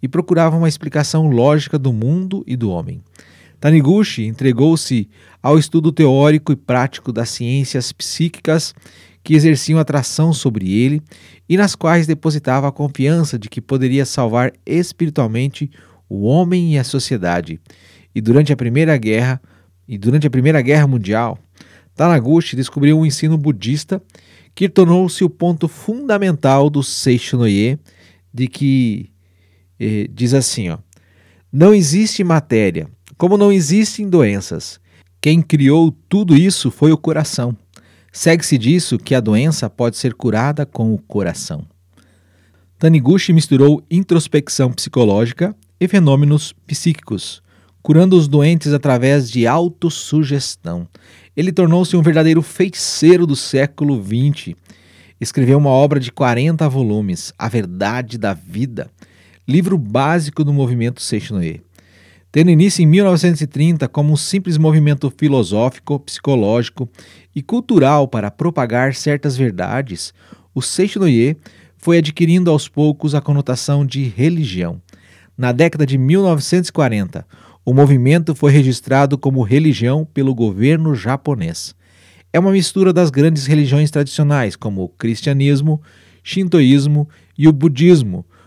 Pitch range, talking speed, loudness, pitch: 115-160 Hz, 125 wpm, -15 LUFS, 140 Hz